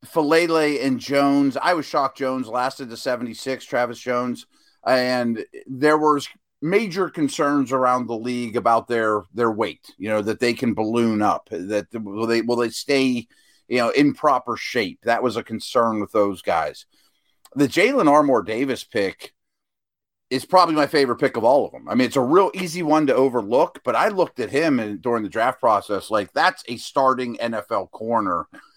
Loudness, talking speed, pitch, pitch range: -21 LUFS, 180 wpm, 125 Hz, 115-145 Hz